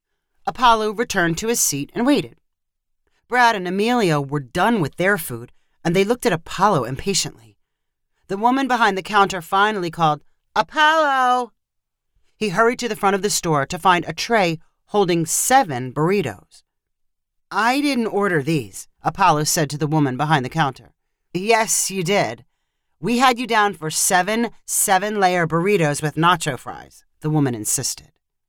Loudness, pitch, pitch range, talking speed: -19 LUFS, 185 Hz, 150-220 Hz, 155 wpm